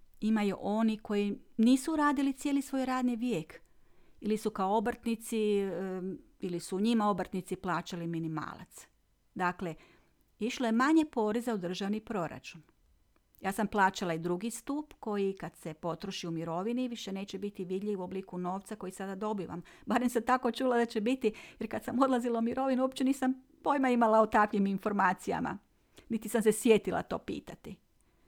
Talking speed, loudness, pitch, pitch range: 160 wpm, -32 LUFS, 215 Hz, 190-240 Hz